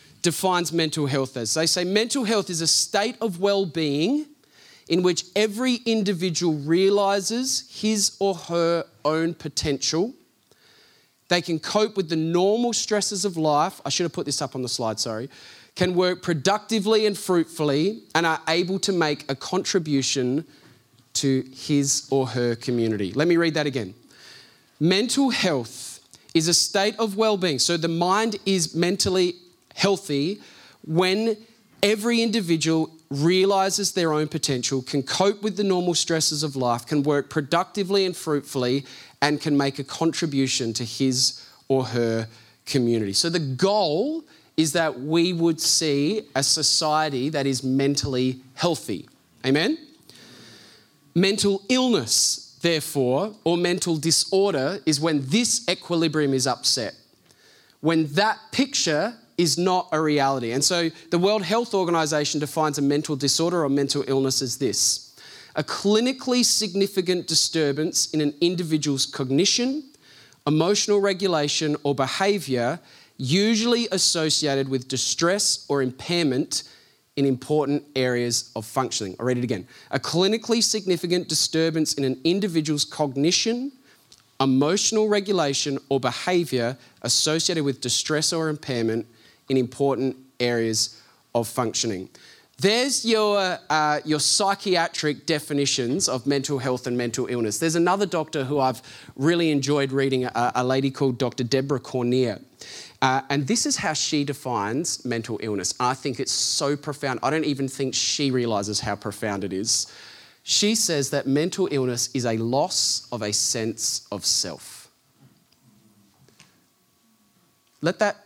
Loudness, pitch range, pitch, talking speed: -23 LUFS, 130-185 Hz, 155 Hz, 140 wpm